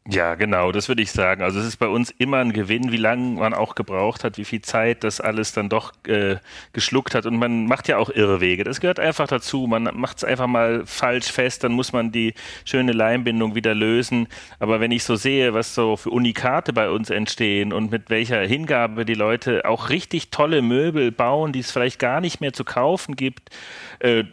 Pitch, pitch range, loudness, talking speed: 115 Hz, 110-125 Hz, -21 LUFS, 220 wpm